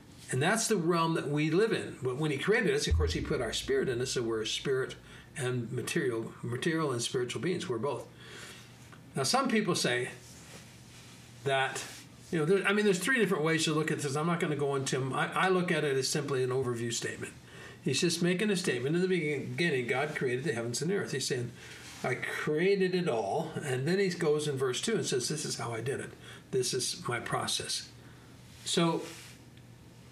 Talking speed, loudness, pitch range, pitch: 215 wpm, -31 LUFS, 130-185 Hz, 155 Hz